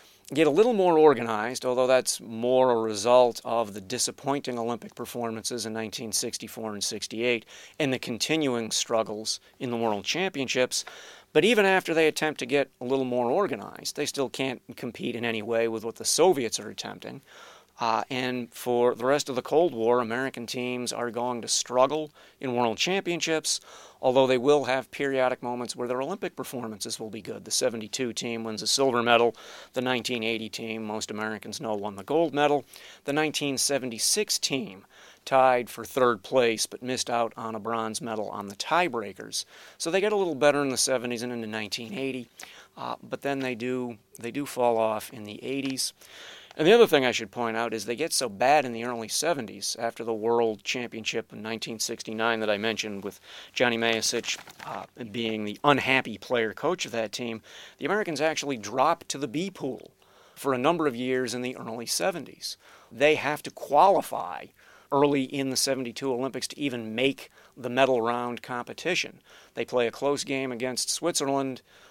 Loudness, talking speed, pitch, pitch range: -27 LUFS, 180 wpm, 125 Hz, 115-135 Hz